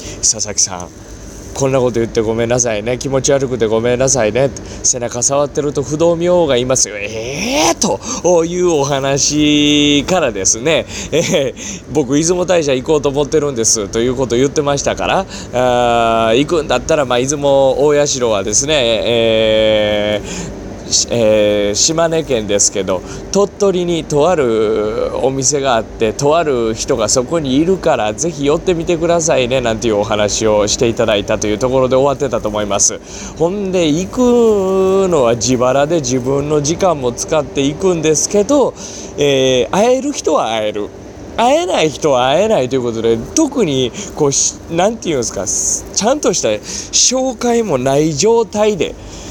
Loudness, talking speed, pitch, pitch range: -14 LUFS, 330 characters per minute, 135 Hz, 115-165 Hz